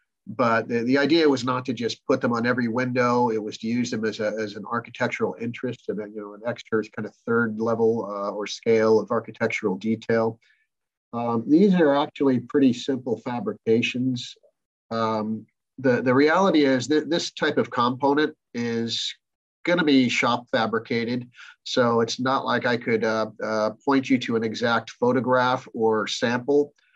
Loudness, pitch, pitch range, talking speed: -23 LUFS, 120 Hz, 110-130 Hz, 175 wpm